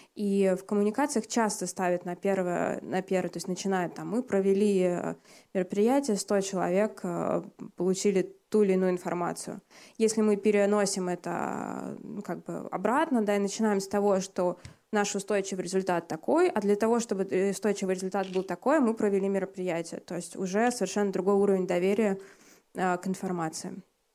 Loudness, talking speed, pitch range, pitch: -29 LUFS, 150 wpm, 185-210 Hz, 195 Hz